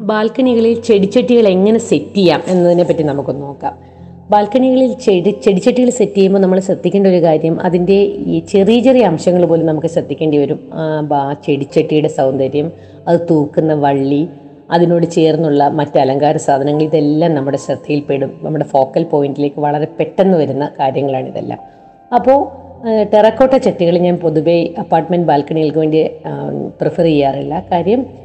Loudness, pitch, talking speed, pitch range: -13 LUFS, 165 Hz, 125 wpm, 145-195 Hz